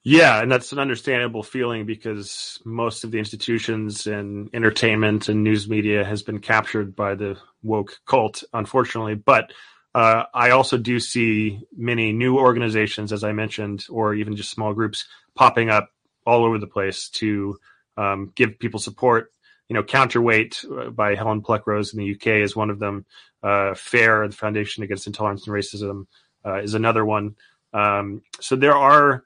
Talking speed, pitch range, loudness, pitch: 170 wpm, 105-115 Hz, -21 LUFS, 110 Hz